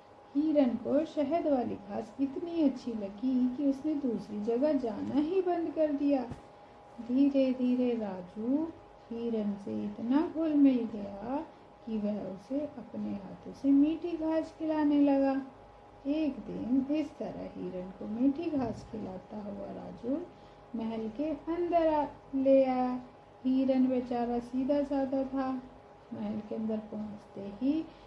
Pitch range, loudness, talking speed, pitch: 230-290 Hz, -32 LUFS, 135 wpm, 265 Hz